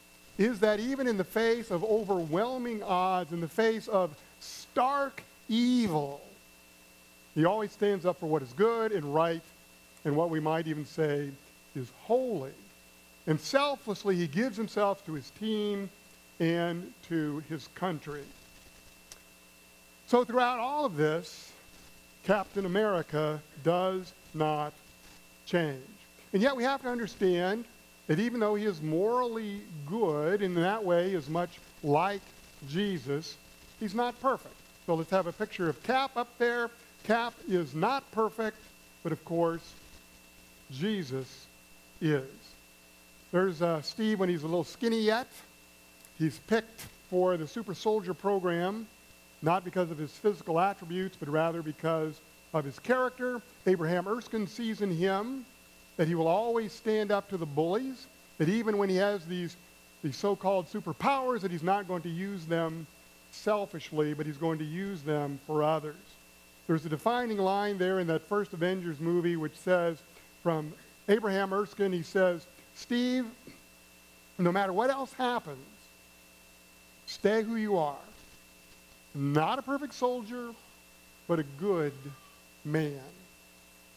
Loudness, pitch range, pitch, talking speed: -31 LUFS, 145-210 Hz, 175 Hz, 140 wpm